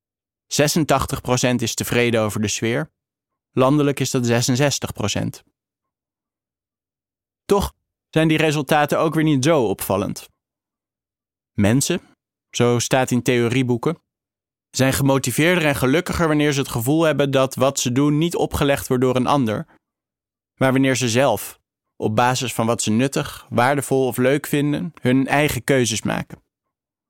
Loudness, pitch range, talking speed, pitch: -19 LUFS, 120-145 Hz, 135 wpm, 130 Hz